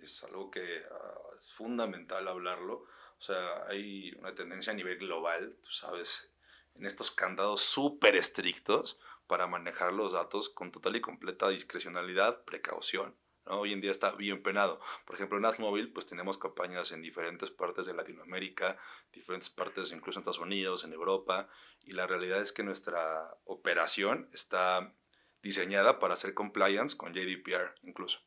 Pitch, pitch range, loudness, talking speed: 100 Hz, 90-105 Hz, -35 LUFS, 155 wpm